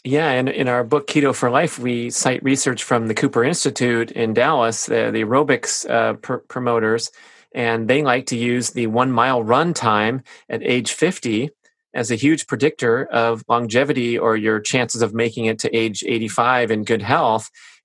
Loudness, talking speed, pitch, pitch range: -19 LUFS, 180 wpm, 120 Hz, 115-140 Hz